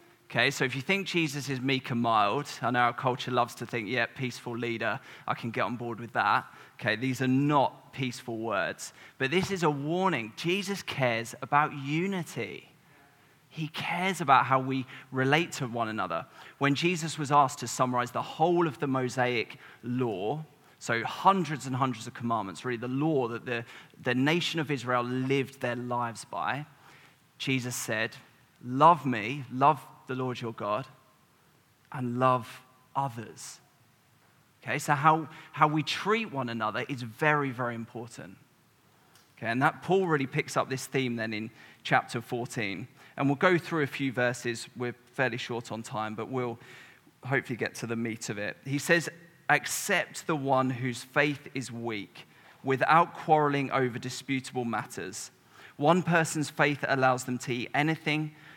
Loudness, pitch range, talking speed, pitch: -29 LUFS, 120-150 Hz, 165 wpm, 130 Hz